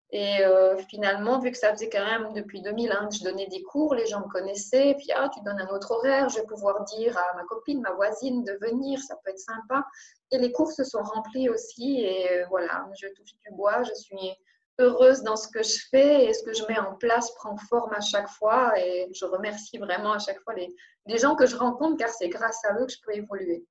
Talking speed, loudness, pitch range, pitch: 255 wpm, -26 LUFS, 195-250 Hz, 220 Hz